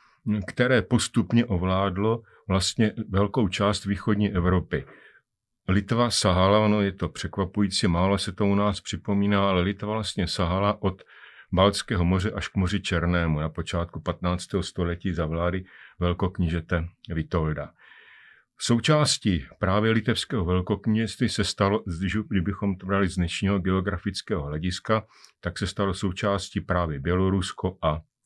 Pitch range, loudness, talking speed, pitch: 90-105 Hz, -25 LUFS, 125 wpm, 100 Hz